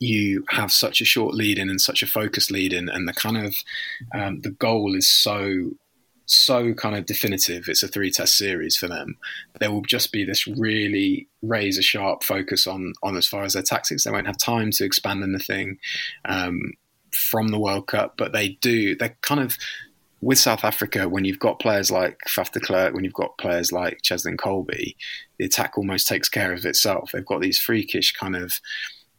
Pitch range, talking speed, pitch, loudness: 95-110 Hz, 200 wpm, 100 Hz, -21 LUFS